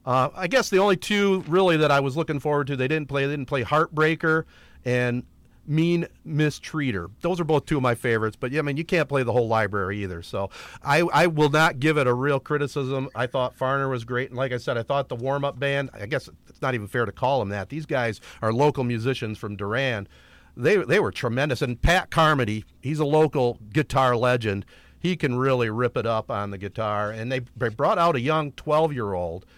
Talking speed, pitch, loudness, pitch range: 215 wpm, 135 Hz, -24 LUFS, 120-155 Hz